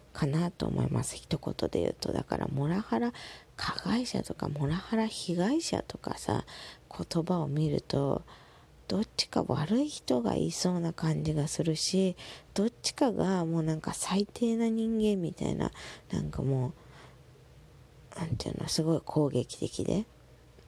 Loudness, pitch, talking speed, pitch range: -31 LUFS, 170 Hz, 285 characters per minute, 155-210 Hz